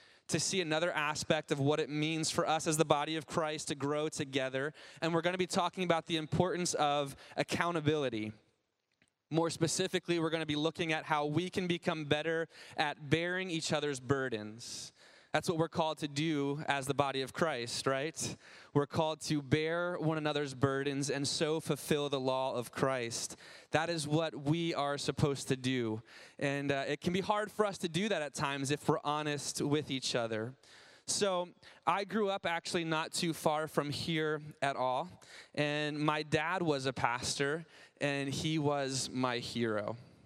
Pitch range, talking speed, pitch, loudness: 140-165 Hz, 180 wpm, 150 Hz, -34 LUFS